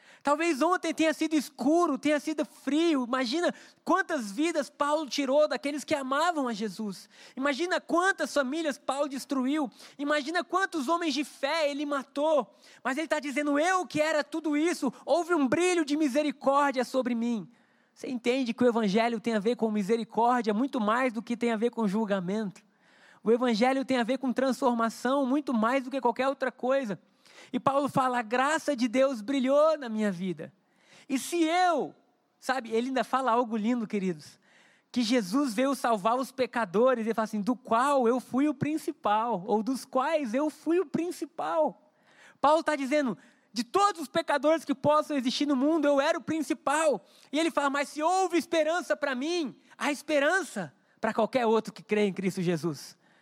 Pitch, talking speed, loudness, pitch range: 270 Hz, 175 wpm, -28 LUFS, 240-300 Hz